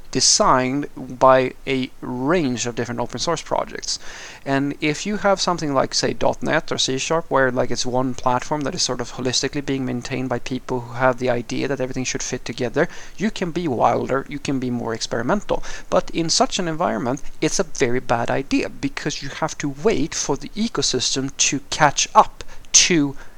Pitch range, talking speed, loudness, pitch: 125-150 Hz, 190 wpm, -21 LUFS, 135 Hz